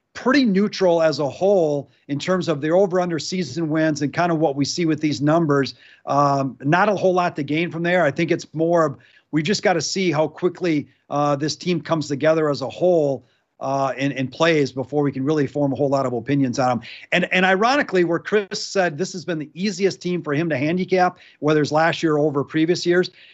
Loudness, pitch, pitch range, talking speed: -20 LUFS, 160 Hz, 145-180 Hz, 230 wpm